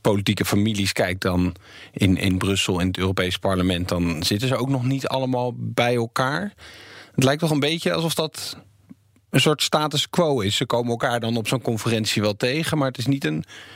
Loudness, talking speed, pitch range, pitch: -22 LUFS, 200 wpm, 95-135 Hz, 120 Hz